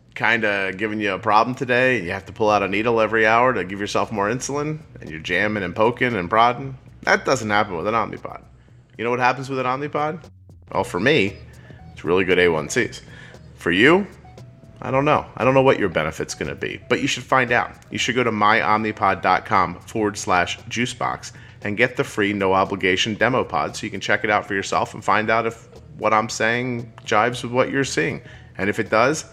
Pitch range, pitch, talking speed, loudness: 105-125 Hz, 115 Hz, 215 wpm, -20 LUFS